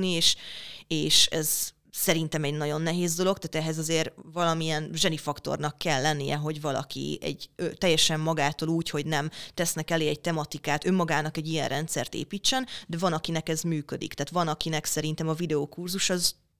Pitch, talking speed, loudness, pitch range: 160 Hz, 165 wpm, -27 LUFS, 150-170 Hz